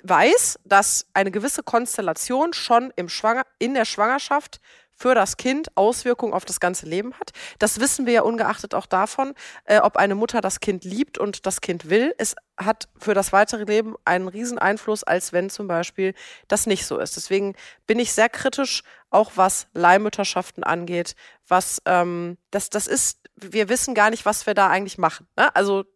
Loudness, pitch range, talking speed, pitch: -21 LUFS, 190-235 Hz, 185 wpm, 210 Hz